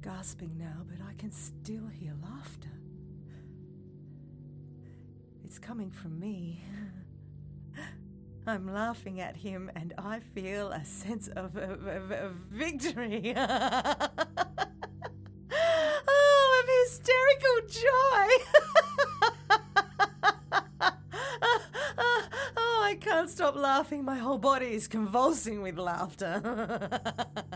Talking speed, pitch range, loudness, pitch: 90 wpm, 180-300 Hz, -29 LUFS, 225 Hz